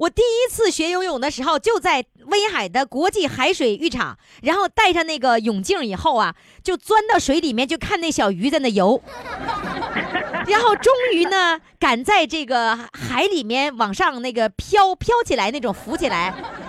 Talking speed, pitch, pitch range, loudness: 255 characters per minute, 335 Hz, 265-405 Hz, -19 LUFS